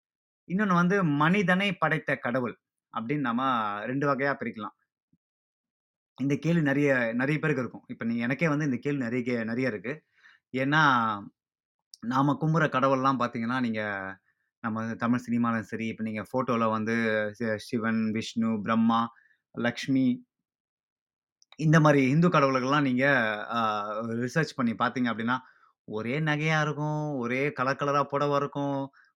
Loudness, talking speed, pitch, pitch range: -27 LUFS, 125 wpm, 130 Hz, 115-145 Hz